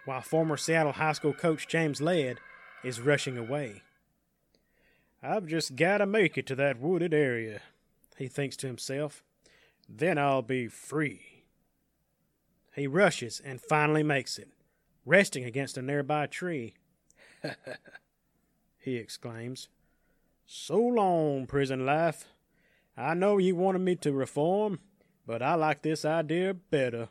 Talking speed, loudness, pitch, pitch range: 130 wpm, -29 LUFS, 150 Hz, 130-165 Hz